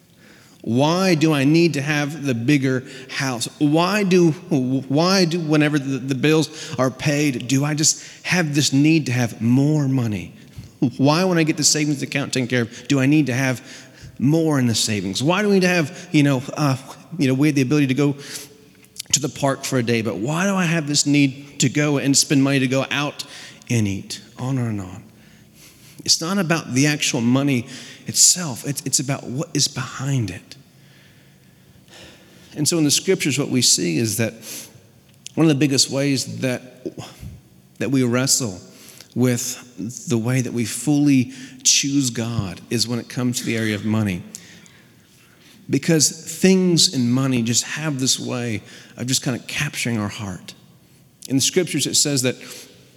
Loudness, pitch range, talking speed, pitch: -19 LUFS, 125-150 Hz, 185 wpm, 135 Hz